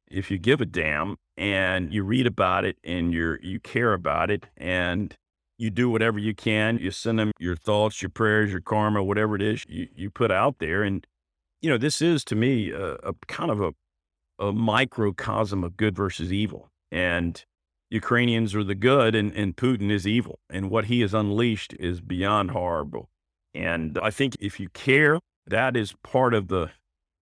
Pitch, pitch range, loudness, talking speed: 105 Hz, 90-115 Hz, -25 LUFS, 190 wpm